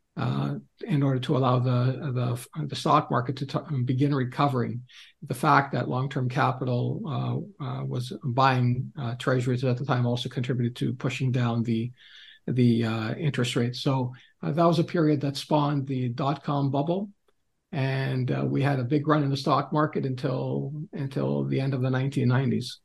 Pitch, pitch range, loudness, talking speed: 130 Hz, 125-145 Hz, -27 LUFS, 175 wpm